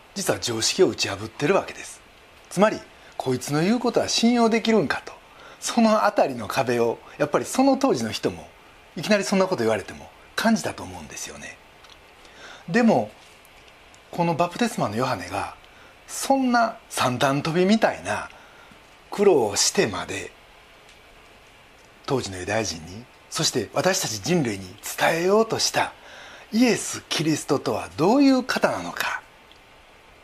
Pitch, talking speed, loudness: 175 Hz, 300 characters per minute, -23 LUFS